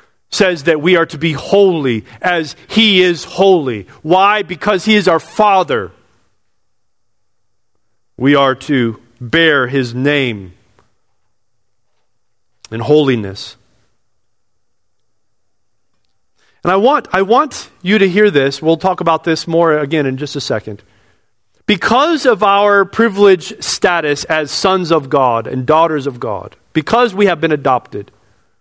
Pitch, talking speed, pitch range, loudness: 140 Hz, 130 wpm, 115-180 Hz, -13 LUFS